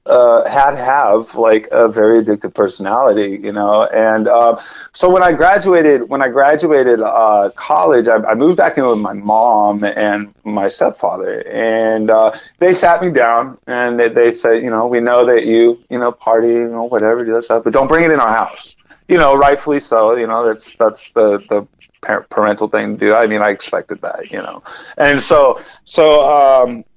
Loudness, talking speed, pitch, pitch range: -12 LUFS, 200 wpm, 115 Hz, 105-135 Hz